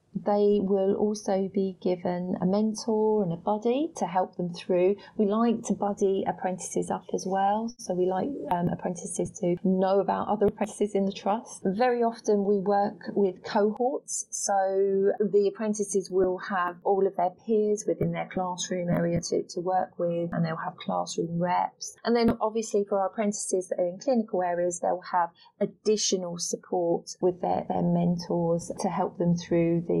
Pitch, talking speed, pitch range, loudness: 195 Hz, 175 wpm, 180-210 Hz, -27 LUFS